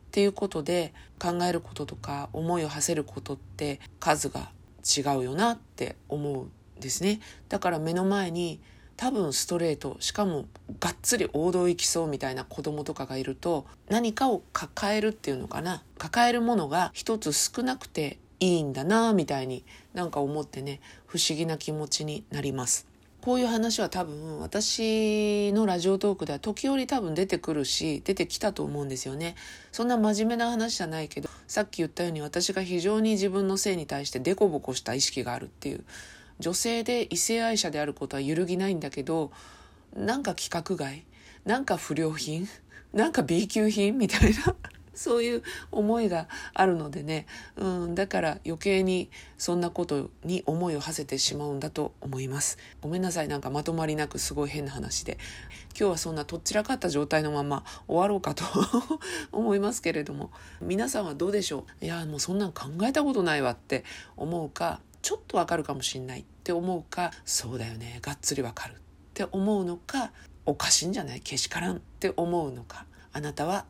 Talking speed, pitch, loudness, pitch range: 380 characters per minute, 170 Hz, -29 LUFS, 145-200 Hz